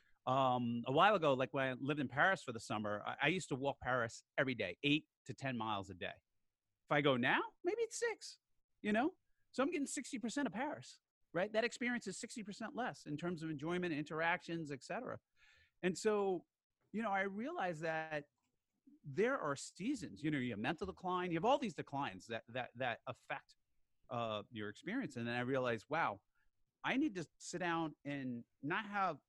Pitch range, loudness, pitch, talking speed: 125-210 Hz, -40 LUFS, 160 Hz, 195 wpm